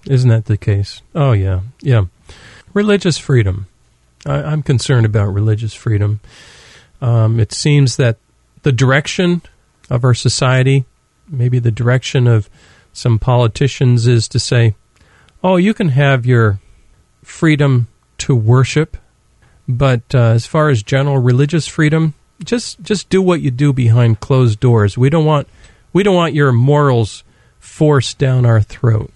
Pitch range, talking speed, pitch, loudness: 115-145 Hz, 145 wpm, 125 Hz, -14 LUFS